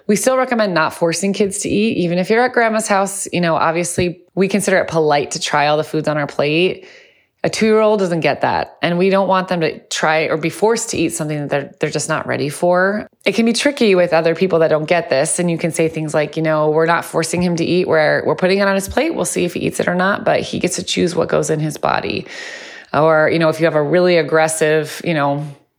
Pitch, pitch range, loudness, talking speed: 170 Hz, 155-195 Hz, -16 LUFS, 270 wpm